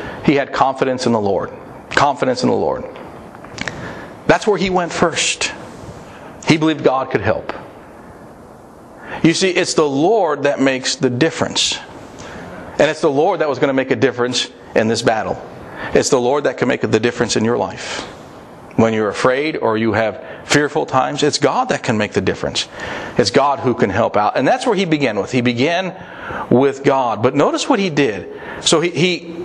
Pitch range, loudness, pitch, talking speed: 125-165 Hz, -16 LUFS, 145 Hz, 190 wpm